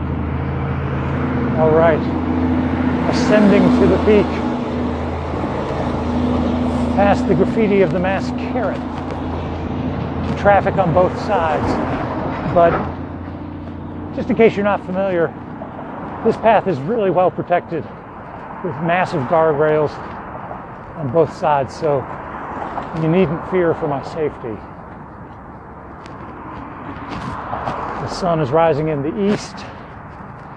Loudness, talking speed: -18 LUFS, 100 wpm